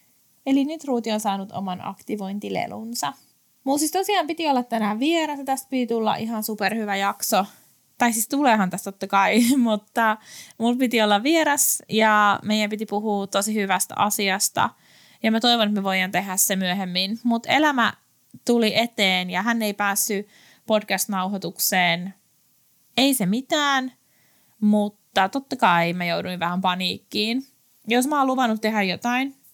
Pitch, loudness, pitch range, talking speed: 215 Hz, -22 LUFS, 195-245 Hz, 150 wpm